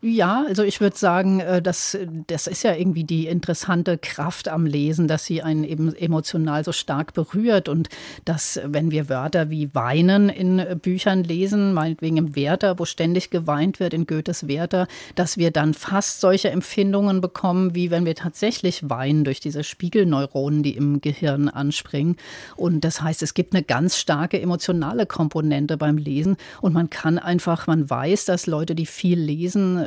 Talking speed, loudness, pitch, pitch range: 170 wpm, -22 LUFS, 170 Hz, 155-185 Hz